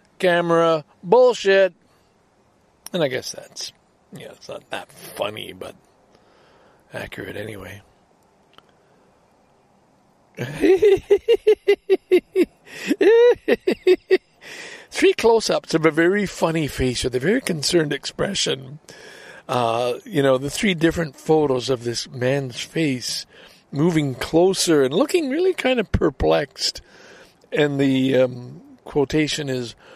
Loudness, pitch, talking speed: -20 LUFS, 170 Hz, 100 wpm